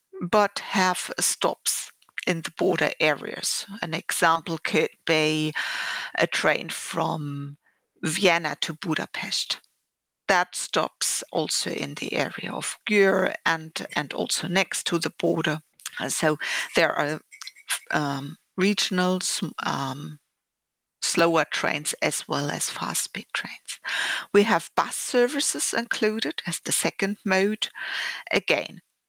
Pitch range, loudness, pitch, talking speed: 160-195 Hz, -25 LUFS, 175 Hz, 115 wpm